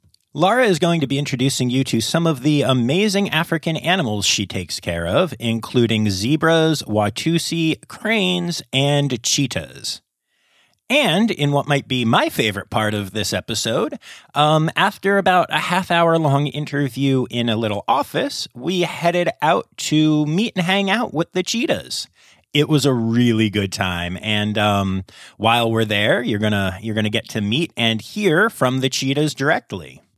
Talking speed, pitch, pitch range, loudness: 165 wpm, 135 Hz, 110-165 Hz, -19 LUFS